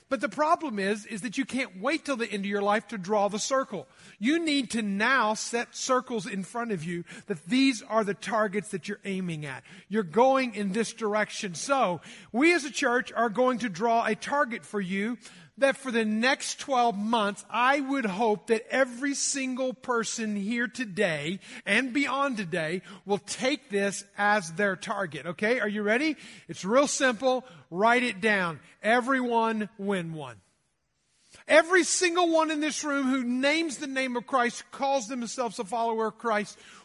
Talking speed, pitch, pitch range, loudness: 180 wpm, 230 Hz, 205-260 Hz, -27 LUFS